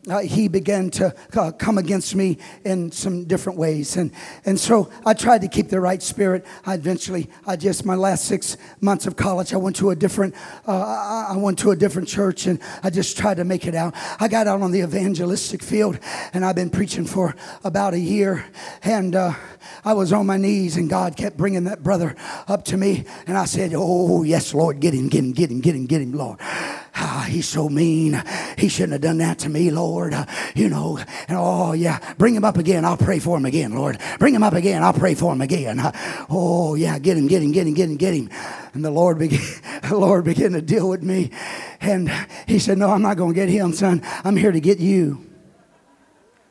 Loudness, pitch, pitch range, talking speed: -20 LUFS, 185 Hz, 170-195 Hz, 225 wpm